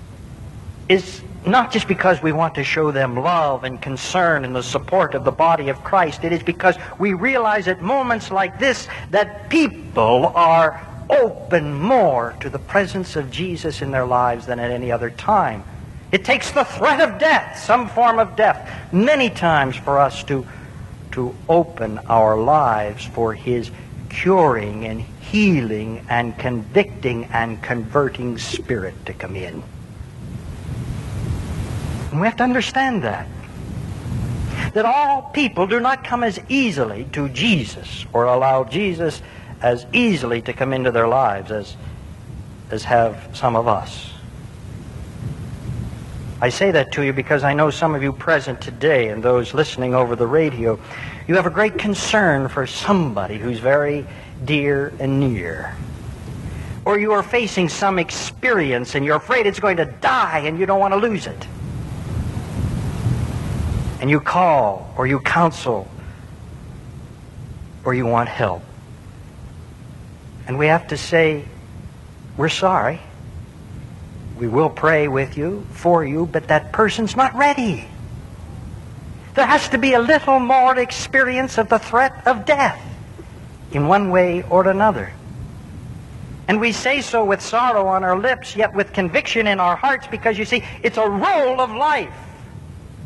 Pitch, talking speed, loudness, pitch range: 145 Hz, 150 wpm, -18 LUFS, 120-195 Hz